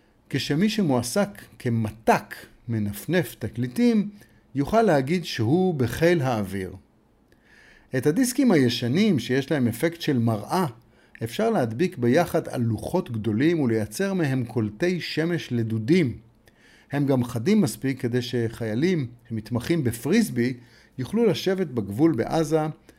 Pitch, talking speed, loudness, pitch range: 135 Hz, 105 wpm, -24 LUFS, 115-175 Hz